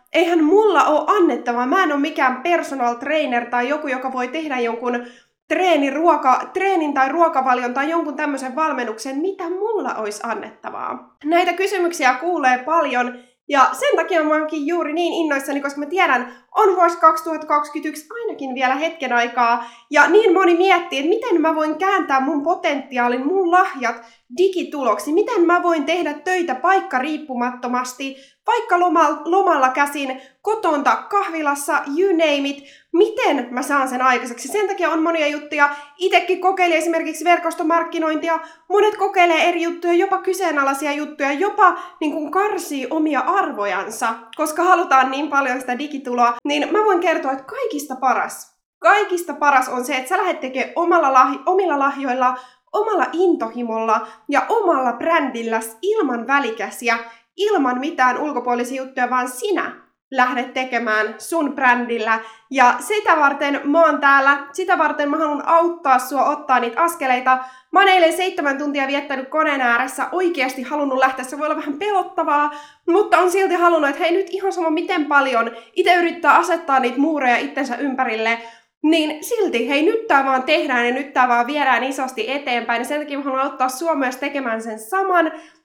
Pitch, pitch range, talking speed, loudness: 295 Hz, 255-345 Hz, 155 wpm, -18 LUFS